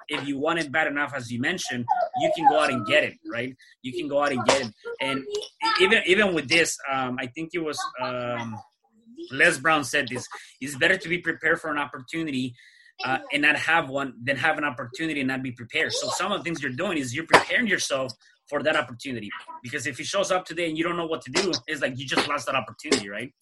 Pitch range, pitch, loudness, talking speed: 130-175 Hz, 155 Hz, -25 LUFS, 245 wpm